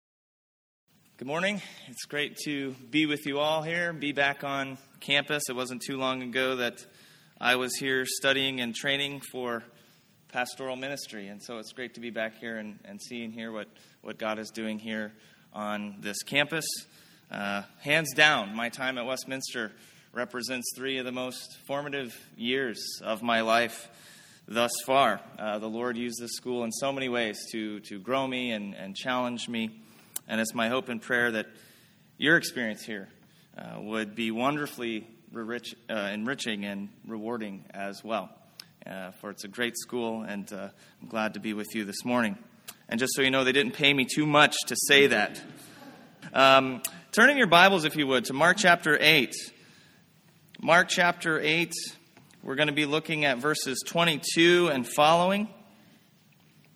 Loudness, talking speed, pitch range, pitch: -27 LUFS, 170 wpm, 115-145 Hz, 125 Hz